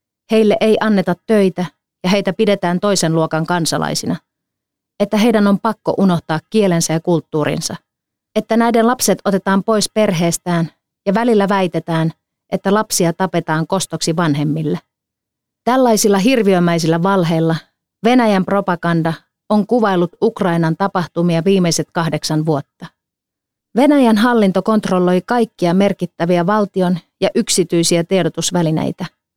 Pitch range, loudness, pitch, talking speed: 165-210 Hz, -16 LUFS, 185 Hz, 110 wpm